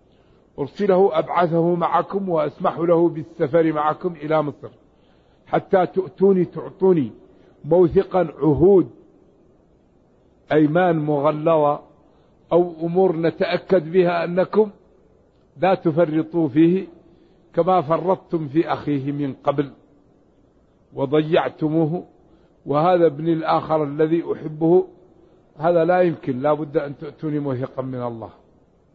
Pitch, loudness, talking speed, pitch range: 165 Hz, -20 LUFS, 95 wpm, 150-180 Hz